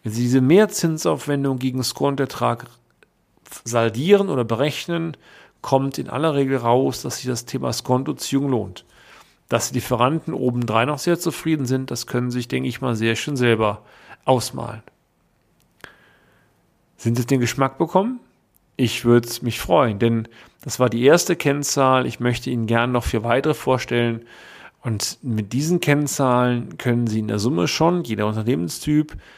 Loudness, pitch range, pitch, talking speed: -21 LUFS, 115-140 Hz, 125 Hz, 150 wpm